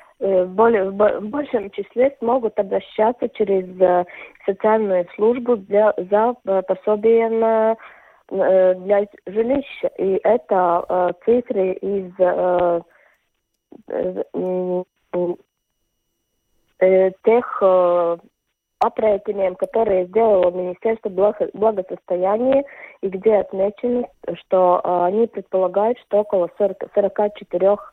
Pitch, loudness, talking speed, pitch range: 205 Hz, -19 LUFS, 85 wpm, 185-225 Hz